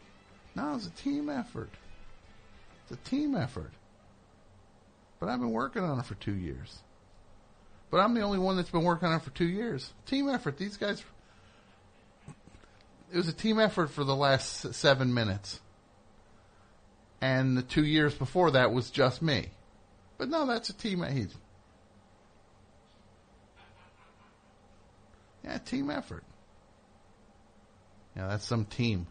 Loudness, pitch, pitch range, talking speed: -31 LUFS, 110 Hz, 100-160 Hz, 140 wpm